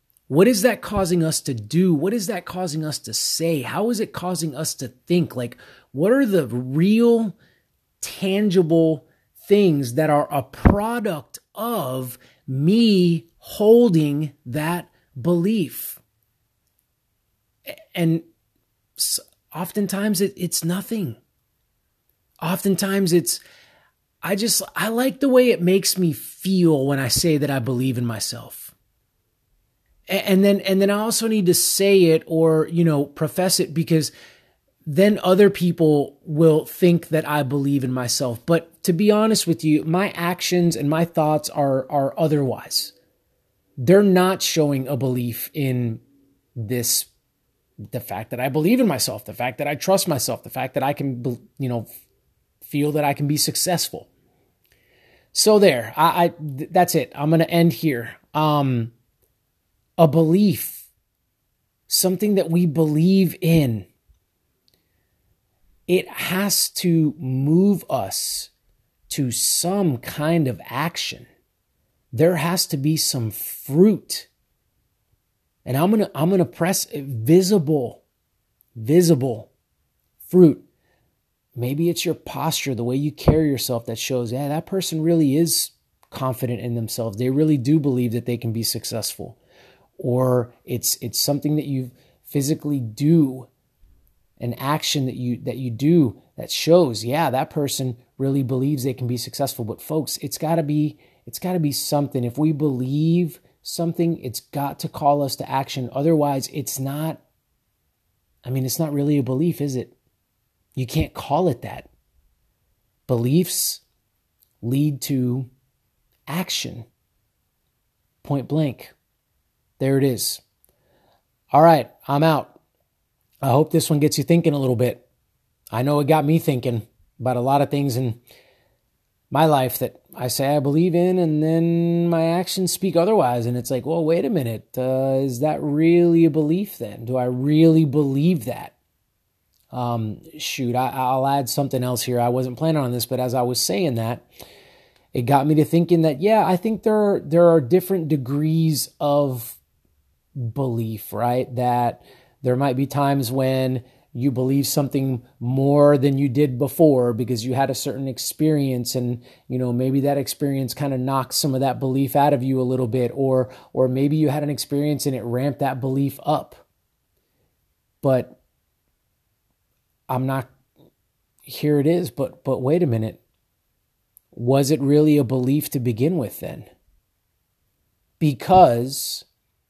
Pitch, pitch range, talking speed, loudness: 140 Hz, 125-165 Hz, 150 wpm, -20 LUFS